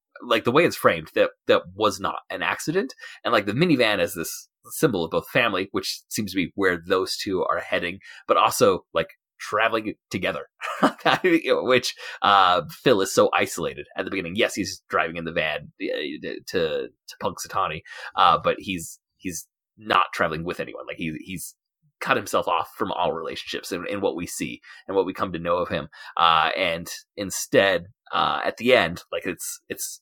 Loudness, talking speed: -23 LUFS, 190 wpm